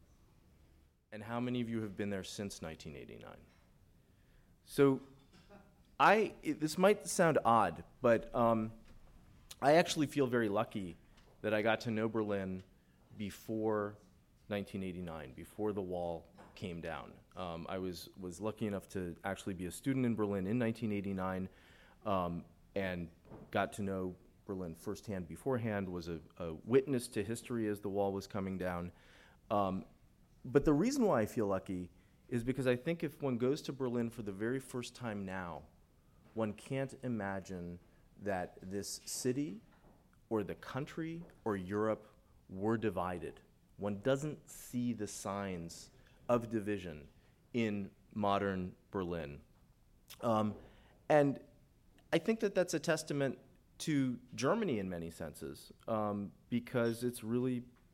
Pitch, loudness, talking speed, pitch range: 105 Hz, -37 LUFS, 140 wpm, 95-125 Hz